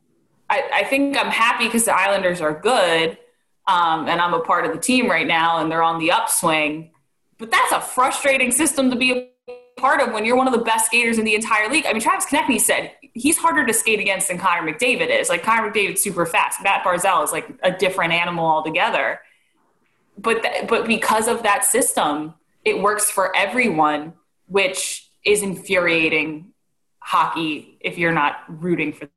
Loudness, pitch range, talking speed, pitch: -18 LUFS, 165-245 Hz, 190 wpm, 200 Hz